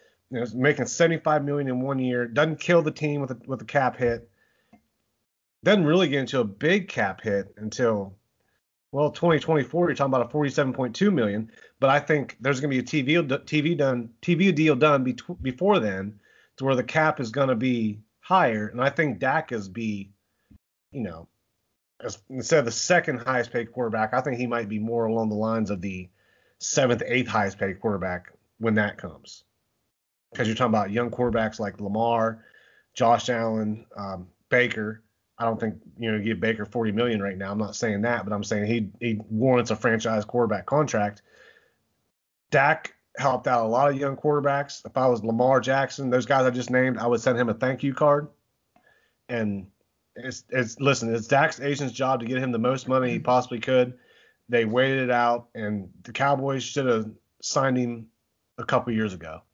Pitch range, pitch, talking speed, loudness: 110-140 Hz, 120 Hz, 200 wpm, -25 LUFS